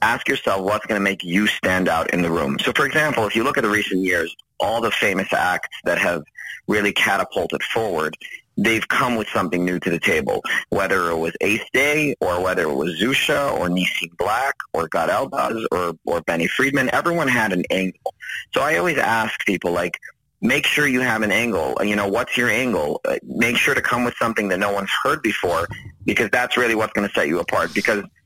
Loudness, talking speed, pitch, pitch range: -20 LUFS, 210 wpm, 95 Hz, 90-110 Hz